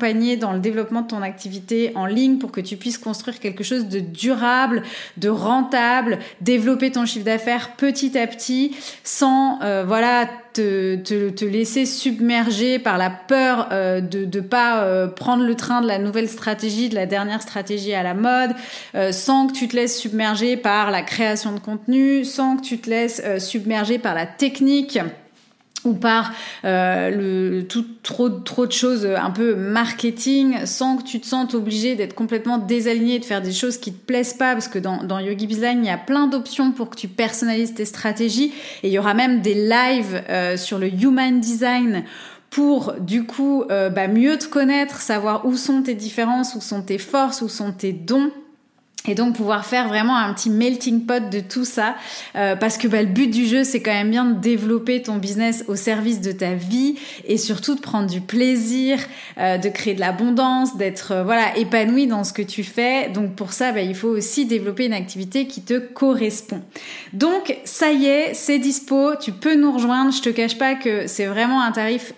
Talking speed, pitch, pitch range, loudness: 205 wpm, 230 Hz, 210-255 Hz, -20 LUFS